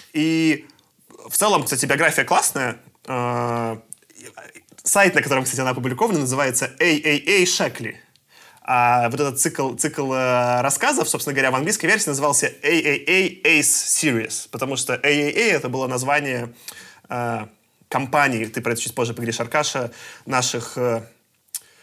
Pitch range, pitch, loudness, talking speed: 120-150 Hz, 130 Hz, -19 LUFS, 125 wpm